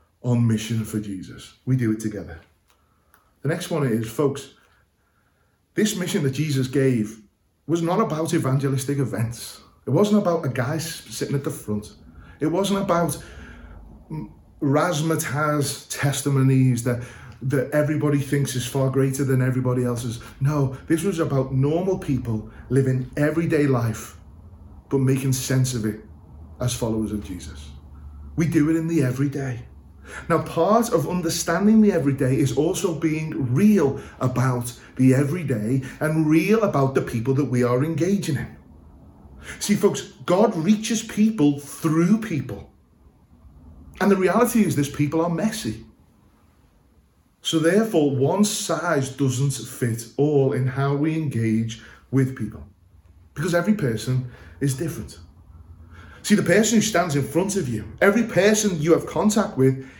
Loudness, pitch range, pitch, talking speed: -22 LUFS, 110-160 Hz, 135 Hz, 140 wpm